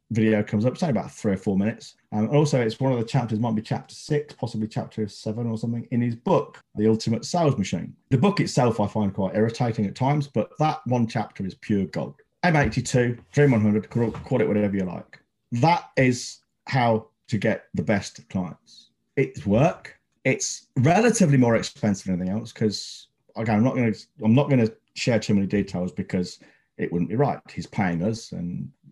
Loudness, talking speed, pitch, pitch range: -24 LUFS, 205 wpm, 115 Hz, 105-130 Hz